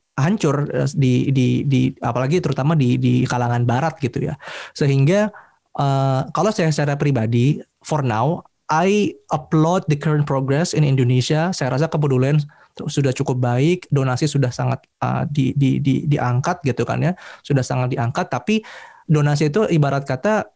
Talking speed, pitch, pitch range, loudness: 150 wpm, 140 Hz, 130-160 Hz, -19 LUFS